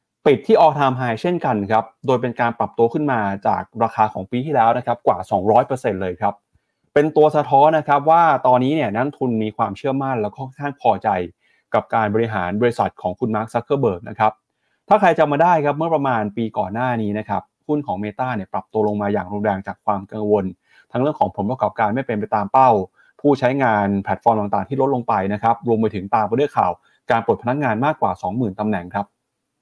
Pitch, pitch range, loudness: 115 Hz, 105-135 Hz, -19 LUFS